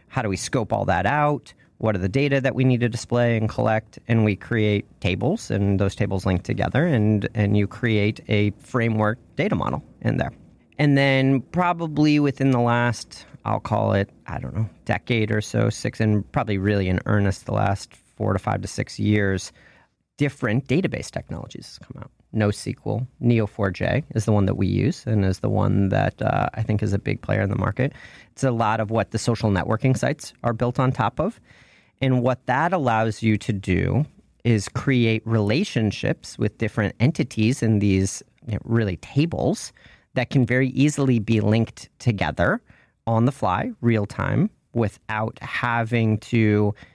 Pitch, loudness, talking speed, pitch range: 115 Hz, -23 LUFS, 180 wpm, 105-130 Hz